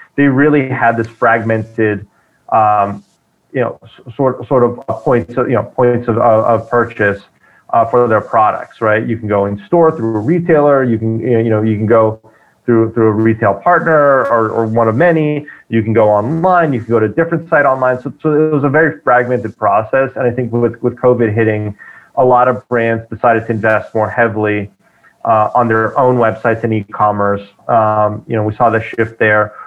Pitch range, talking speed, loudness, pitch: 110-125 Hz, 200 wpm, -13 LUFS, 115 Hz